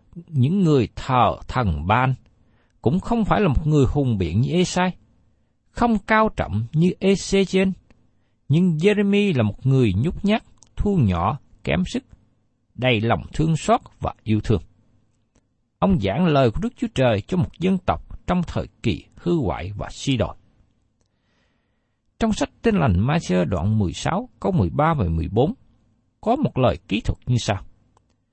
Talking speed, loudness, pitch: 160 wpm, -21 LUFS, 125 Hz